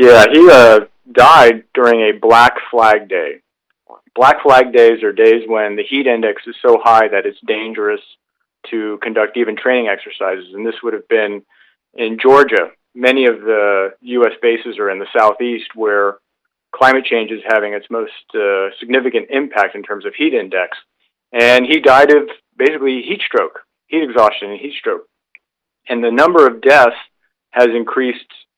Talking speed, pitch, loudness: 165 wpm, 125 Hz, -12 LUFS